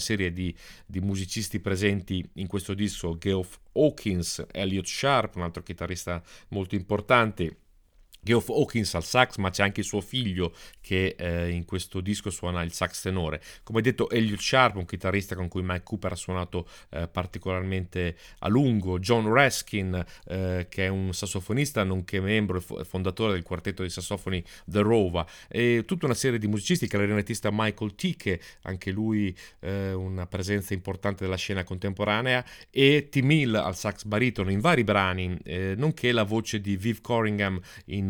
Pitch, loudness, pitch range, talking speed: 95 Hz, -27 LUFS, 90-110 Hz, 165 wpm